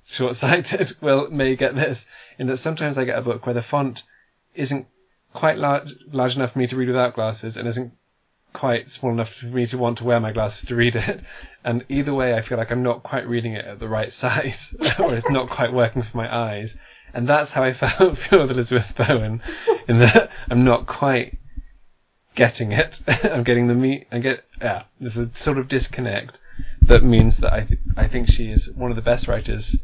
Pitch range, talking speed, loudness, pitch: 115-135 Hz, 215 wpm, -21 LUFS, 125 Hz